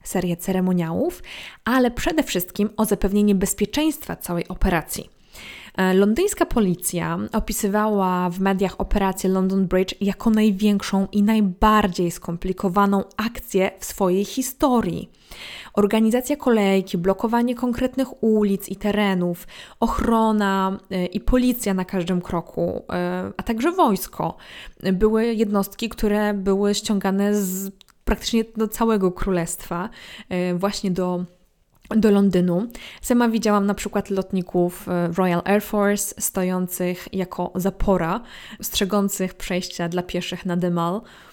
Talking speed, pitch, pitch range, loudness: 105 wpm, 195 Hz, 185-220 Hz, -22 LUFS